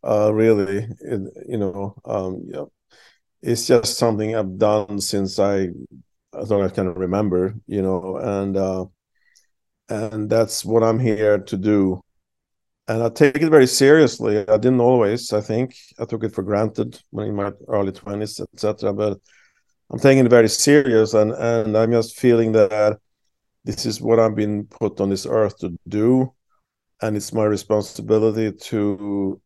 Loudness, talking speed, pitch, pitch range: -19 LUFS, 165 wpm, 105 Hz, 100-115 Hz